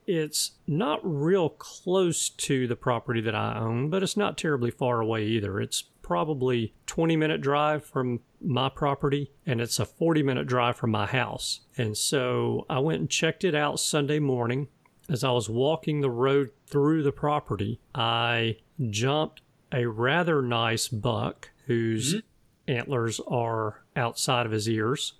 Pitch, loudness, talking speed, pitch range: 130 Hz, -27 LUFS, 155 wpm, 115-150 Hz